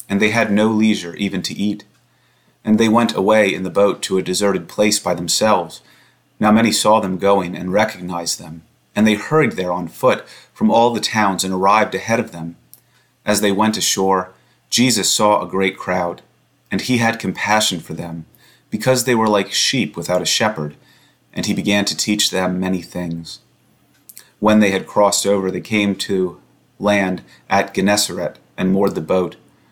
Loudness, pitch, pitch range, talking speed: -17 LUFS, 100 Hz, 90-110 Hz, 180 wpm